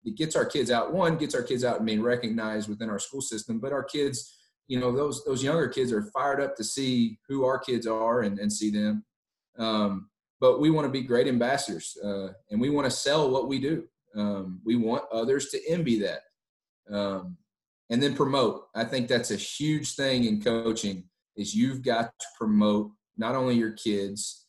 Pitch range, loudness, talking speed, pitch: 105-135 Hz, -28 LUFS, 205 wpm, 115 Hz